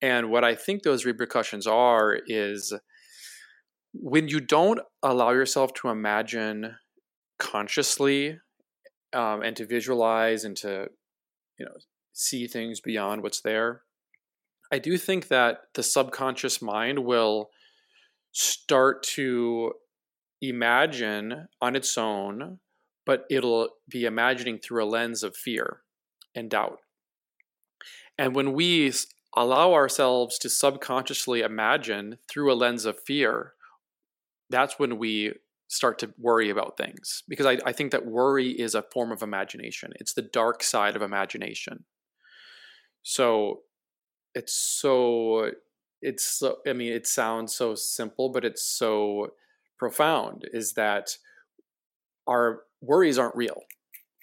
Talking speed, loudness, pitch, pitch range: 125 wpm, -26 LUFS, 120 Hz, 115-135 Hz